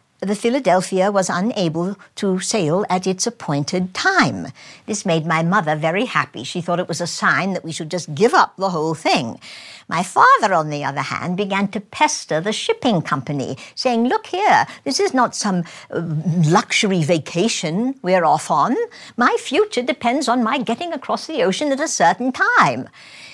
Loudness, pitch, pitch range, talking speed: -18 LUFS, 190 Hz, 170-235 Hz, 175 wpm